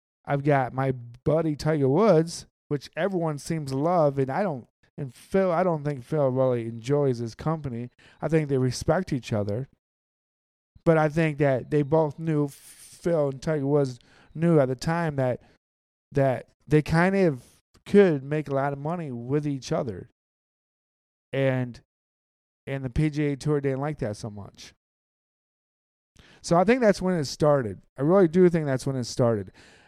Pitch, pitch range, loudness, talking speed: 145 Hz, 125-160 Hz, -25 LUFS, 170 wpm